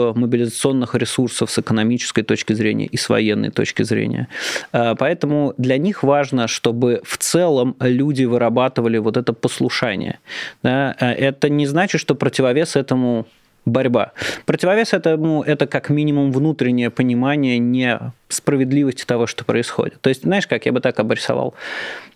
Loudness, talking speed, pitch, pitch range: -18 LUFS, 135 wpm, 130 Hz, 120-145 Hz